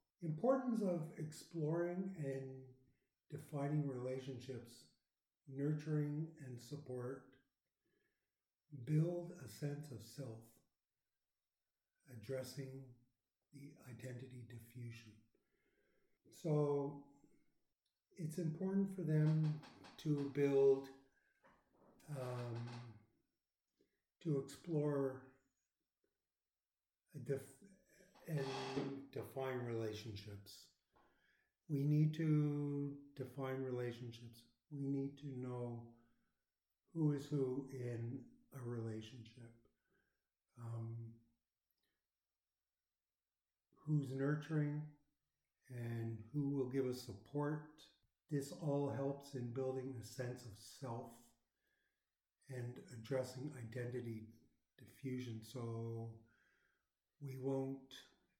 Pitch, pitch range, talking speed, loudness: 135 Hz, 120-145 Hz, 75 wpm, -44 LUFS